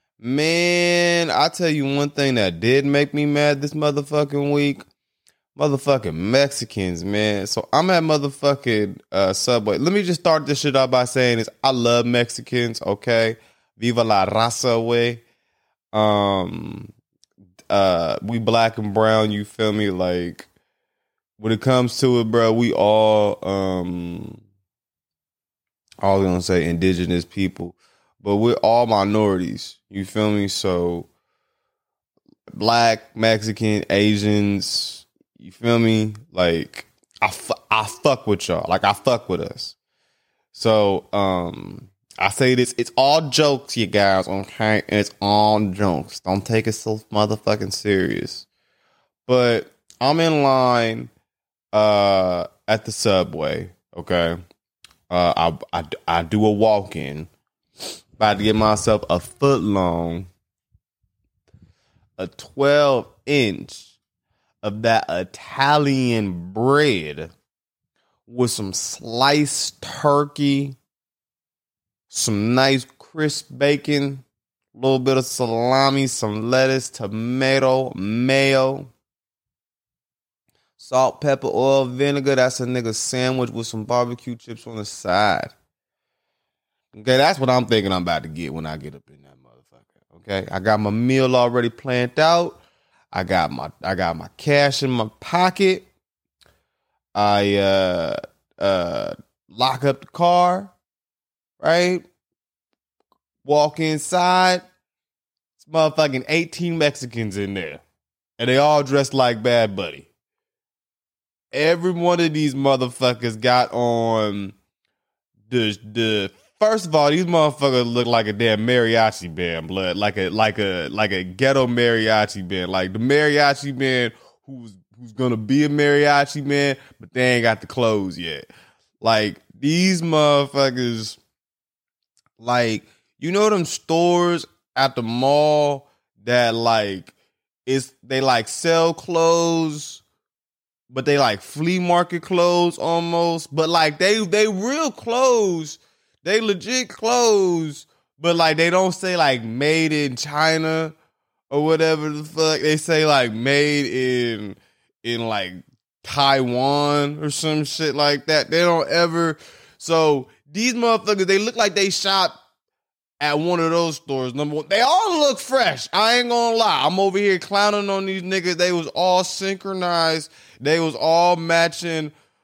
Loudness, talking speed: -19 LUFS, 135 wpm